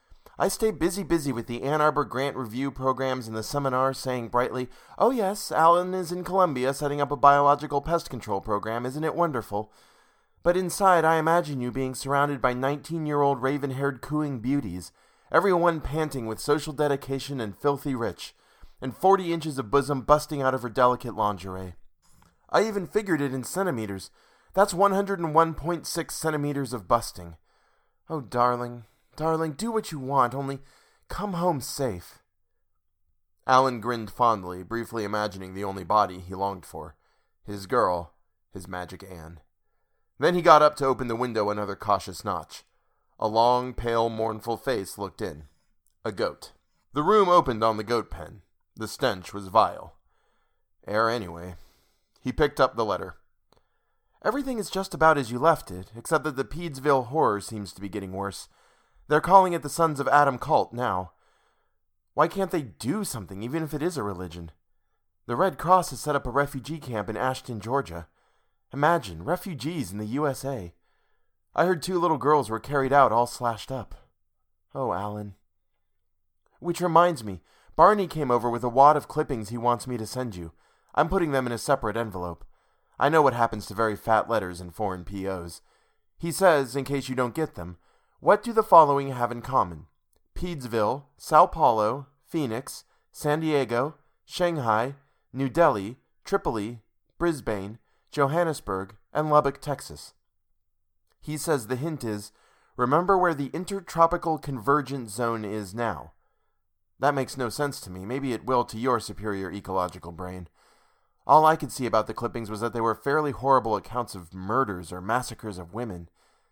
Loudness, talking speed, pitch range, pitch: -26 LUFS, 165 wpm, 105-150 Hz, 125 Hz